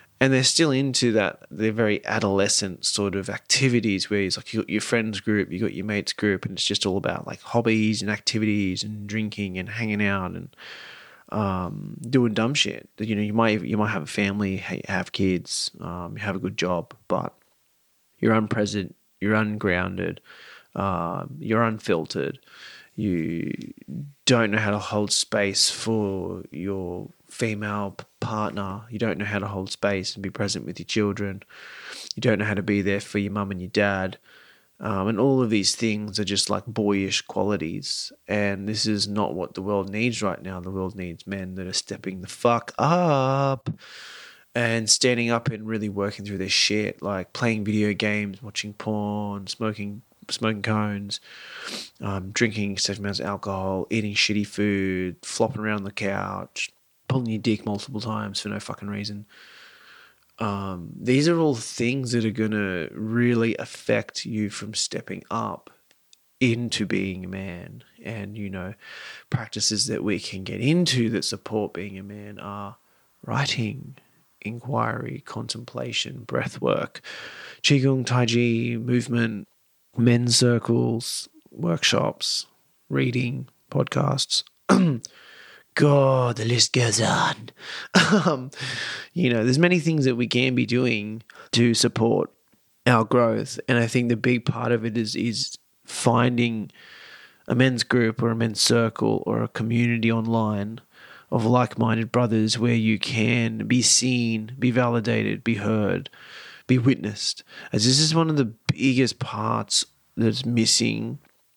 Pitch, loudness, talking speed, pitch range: 110 Hz, -24 LUFS, 155 wpm, 100-120 Hz